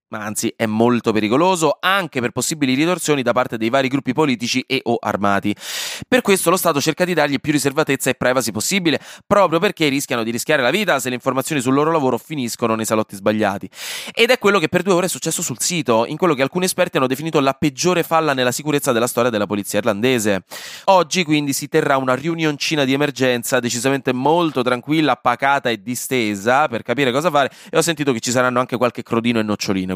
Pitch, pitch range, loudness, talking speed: 135 Hz, 120-155 Hz, -18 LUFS, 210 wpm